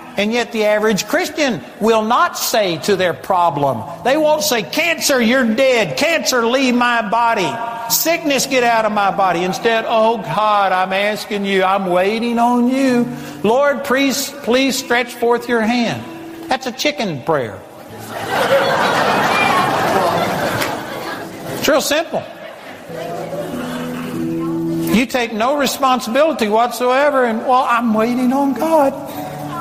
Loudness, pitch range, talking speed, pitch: -16 LUFS, 210-270 Hz, 130 wpm, 240 Hz